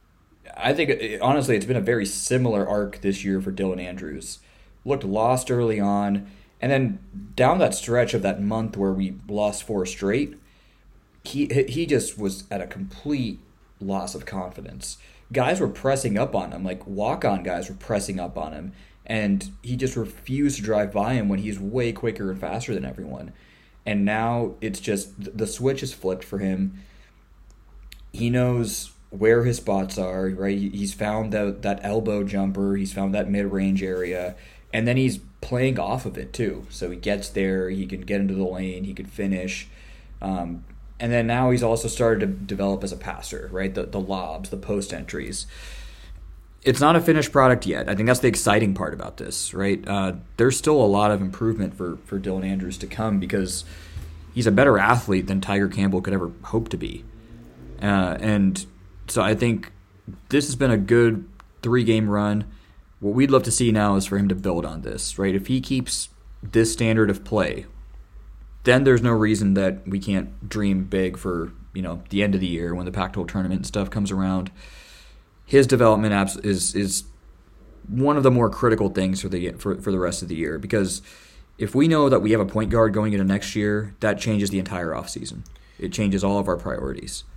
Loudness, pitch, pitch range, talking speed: -23 LUFS, 100 Hz, 95-110 Hz, 195 wpm